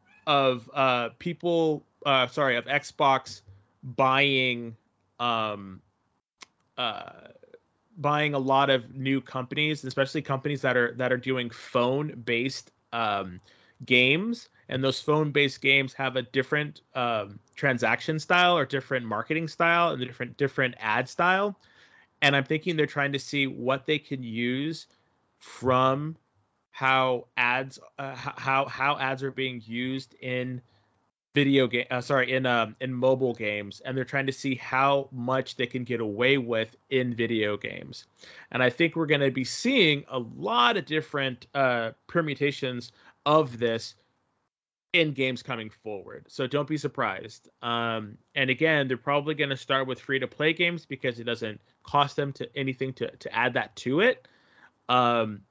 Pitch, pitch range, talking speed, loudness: 130 Hz, 125-145 Hz, 155 wpm, -26 LUFS